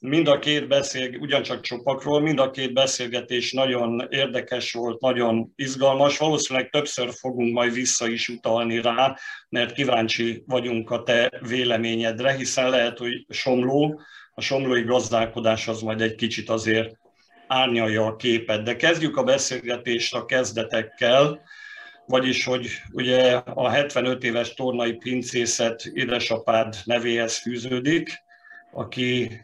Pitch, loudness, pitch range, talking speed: 125 Hz, -23 LUFS, 115-135 Hz, 125 wpm